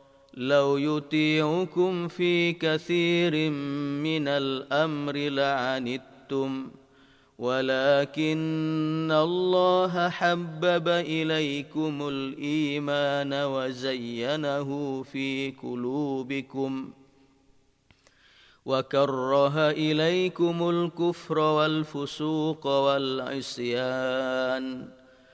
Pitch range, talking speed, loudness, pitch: 135-155 Hz, 45 wpm, -27 LUFS, 140 Hz